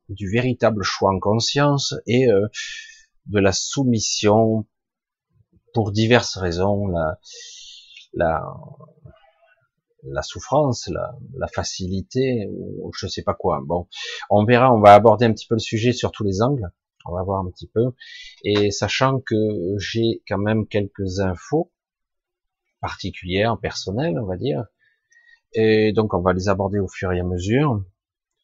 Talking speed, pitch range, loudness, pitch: 150 wpm, 95-130 Hz, -20 LUFS, 110 Hz